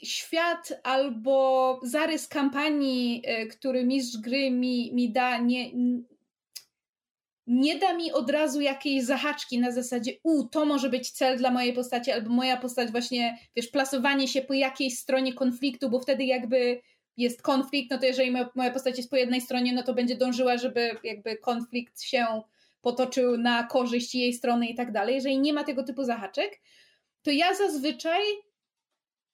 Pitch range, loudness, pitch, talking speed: 245-275 Hz, -27 LUFS, 255 Hz, 160 wpm